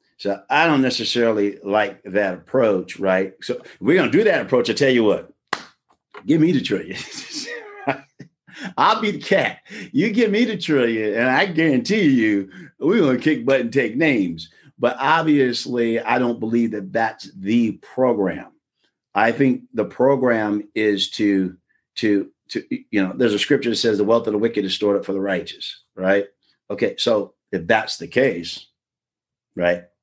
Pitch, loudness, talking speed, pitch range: 115 Hz, -20 LUFS, 175 wpm, 100-130 Hz